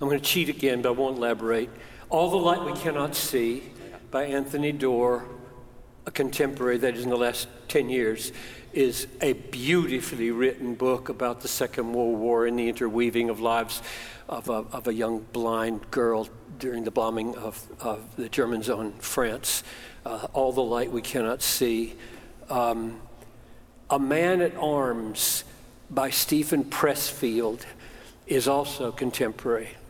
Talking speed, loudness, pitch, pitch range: 155 wpm, -27 LUFS, 125 Hz, 115-135 Hz